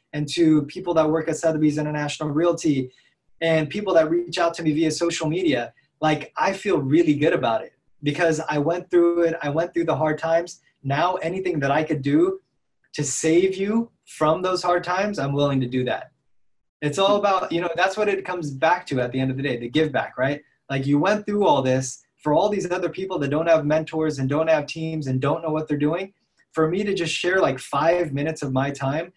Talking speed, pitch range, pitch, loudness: 230 wpm, 145-175 Hz, 160 Hz, -22 LUFS